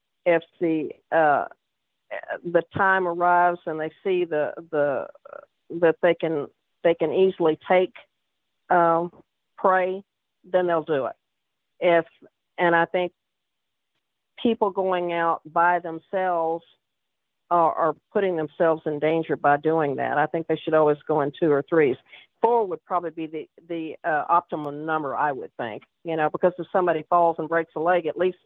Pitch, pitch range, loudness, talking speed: 170 Hz, 160-180 Hz, -23 LUFS, 160 wpm